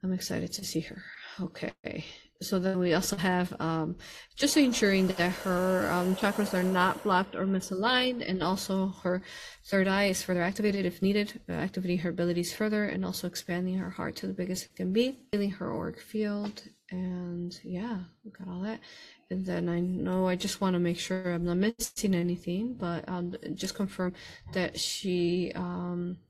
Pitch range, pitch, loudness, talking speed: 180-200 Hz, 185 Hz, -30 LUFS, 180 wpm